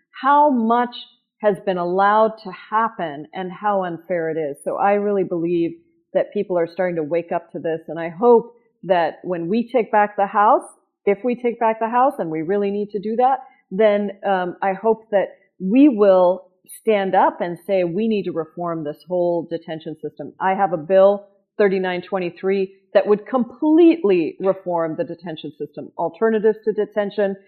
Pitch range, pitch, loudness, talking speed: 175-220 Hz, 195 Hz, -20 LUFS, 180 wpm